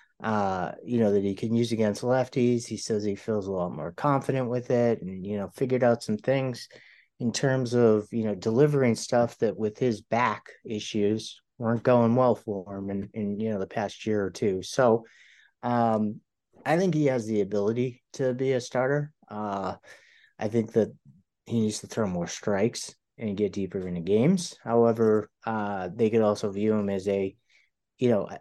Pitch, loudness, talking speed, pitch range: 110 Hz, -27 LUFS, 190 wpm, 105-125 Hz